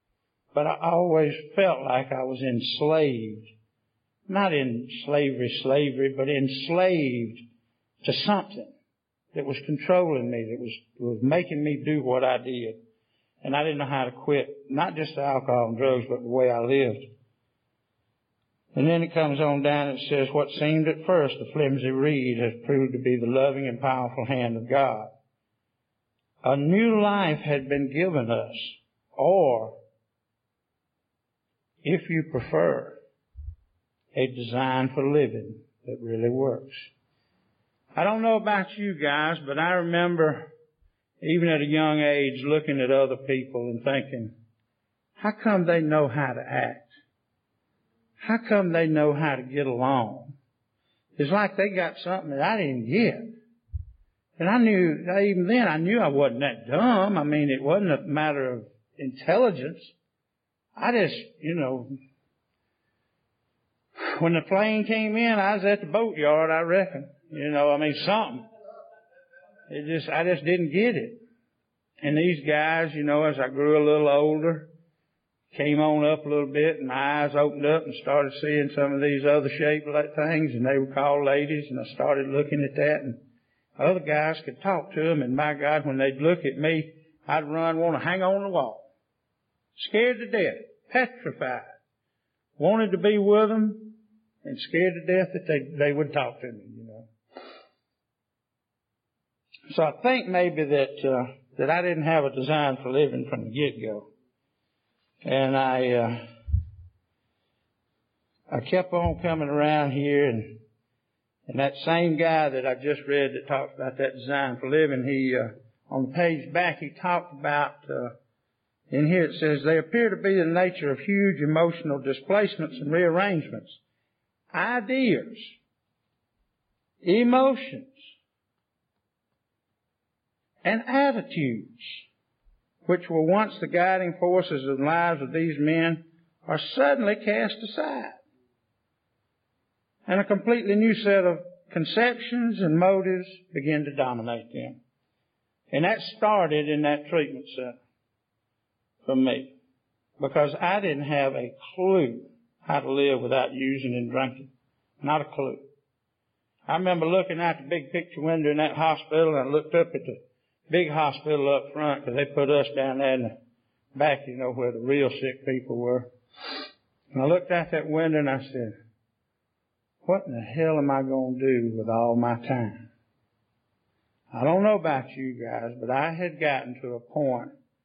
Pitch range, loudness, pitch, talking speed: 130-170 Hz, -25 LUFS, 145 Hz, 160 wpm